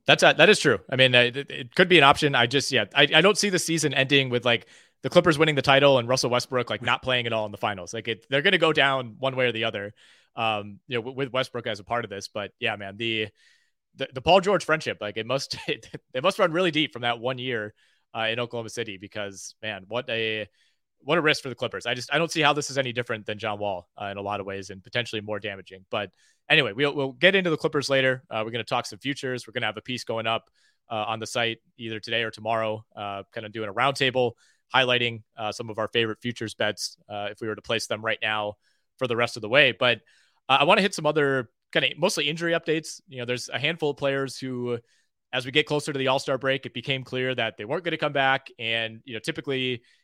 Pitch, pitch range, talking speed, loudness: 125 Hz, 110-140 Hz, 270 wpm, -24 LUFS